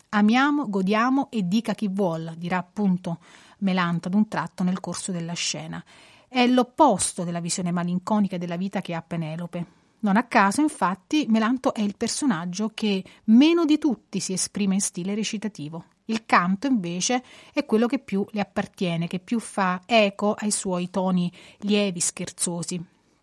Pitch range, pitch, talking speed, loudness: 180-225 Hz, 200 Hz, 160 wpm, -24 LUFS